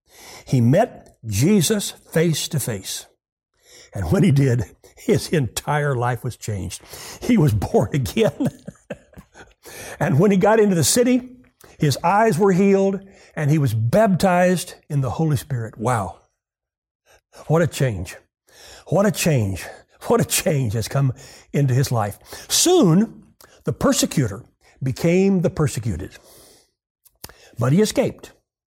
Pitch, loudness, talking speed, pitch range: 150 Hz, -20 LUFS, 130 wpm, 125-195 Hz